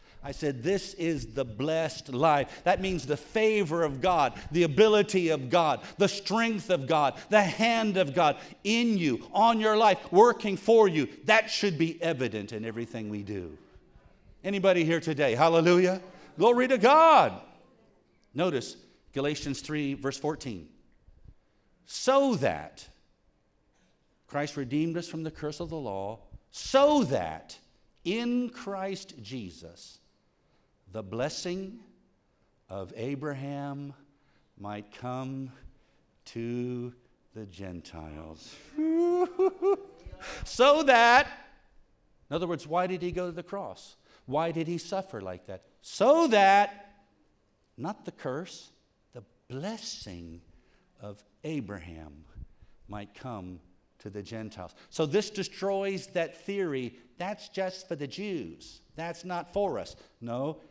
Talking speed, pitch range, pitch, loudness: 125 wpm, 120-200 Hz, 160 Hz, -27 LUFS